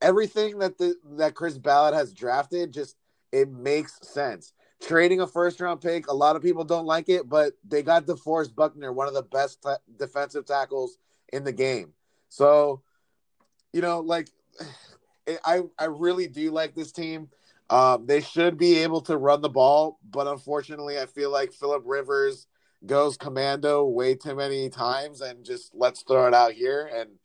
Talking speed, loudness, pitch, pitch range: 180 wpm, -25 LUFS, 150 Hz, 140-170 Hz